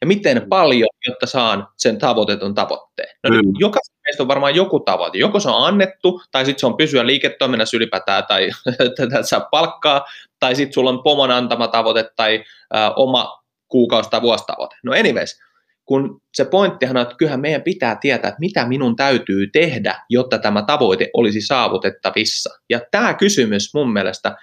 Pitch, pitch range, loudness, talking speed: 130 Hz, 115-150 Hz, -16 LUFS, 170 wpm